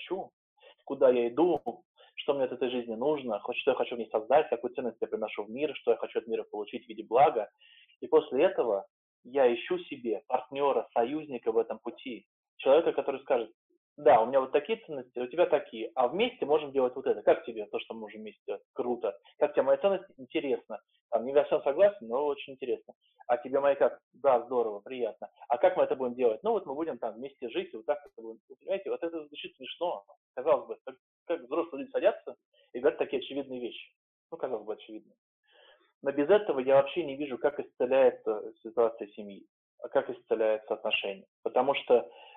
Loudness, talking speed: -30 LUFS, 200 wpm